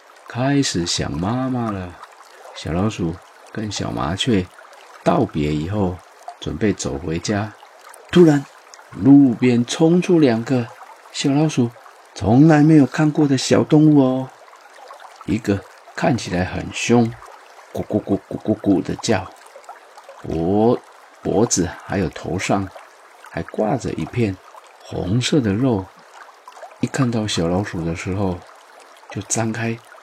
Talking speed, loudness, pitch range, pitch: 175 characters per minute, -19 LUFS, 95-130 Hz, 110 Hz